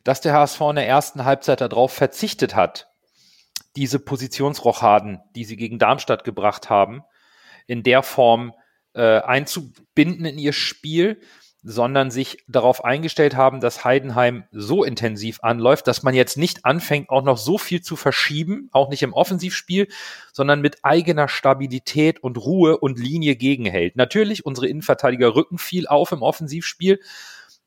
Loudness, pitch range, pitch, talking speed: -19 LUFS, 125-155 Hz, 135 Hz, 145 wpm